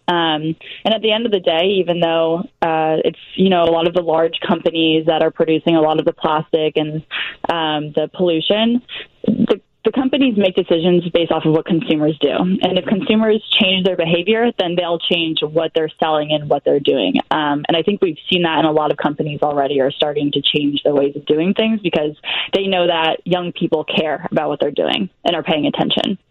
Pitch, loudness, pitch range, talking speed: 165 Hz, -17 LUFS, 155-185 Hz, 220 wpm